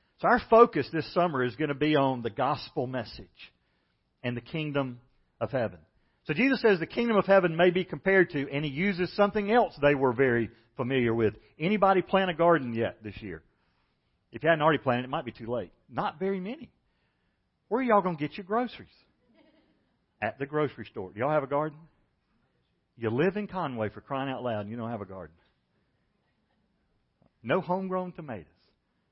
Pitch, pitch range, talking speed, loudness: 145 Hz, 120-185 Hz, 190 wpm, -28 LUFS